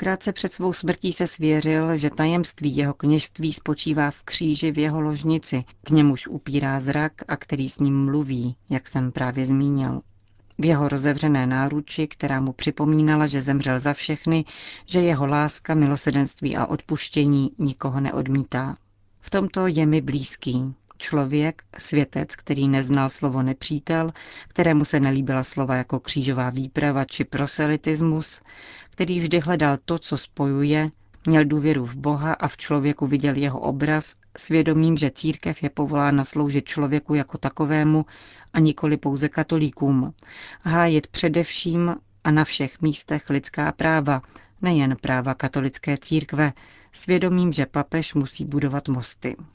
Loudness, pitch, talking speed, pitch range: -23 LUFS, 145 Hz, 140 wpm, 135-155 Hz